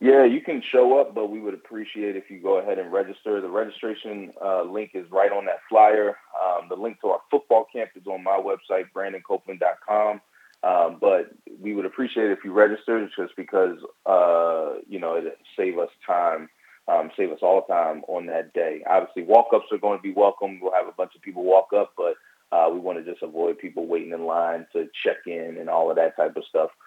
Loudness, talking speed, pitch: -23 LUFS, 225 wpm, 115 Hz